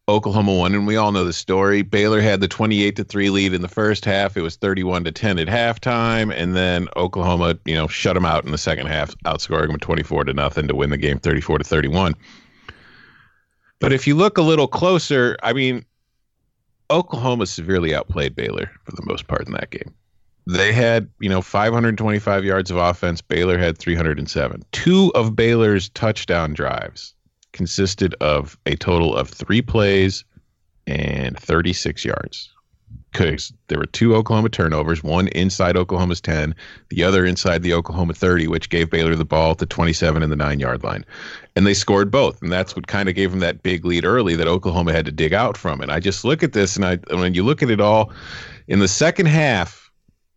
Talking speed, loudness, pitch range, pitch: 195 wpm, -19 LUFS, 85-105 Hz, 95 Hz